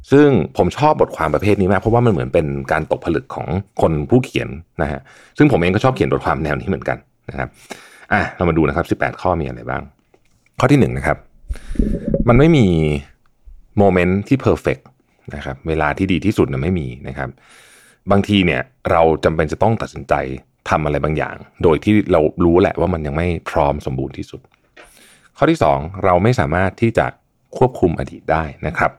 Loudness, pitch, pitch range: -17 LUFS, 90 Hz, 70-105 Hz